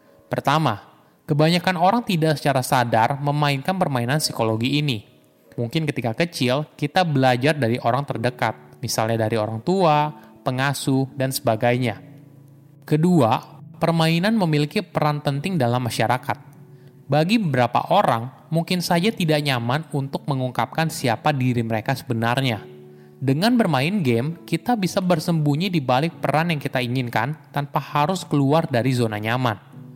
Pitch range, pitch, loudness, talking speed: 125-155 Hz, 140 Hz, -21 LUFS, 125 wpm